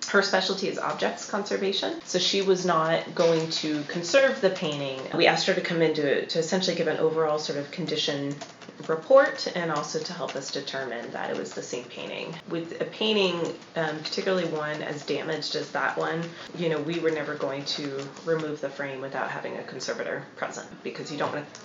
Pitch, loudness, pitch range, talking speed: 160 Hz, -27 LUFS, 150-175 Hz, 200 wpm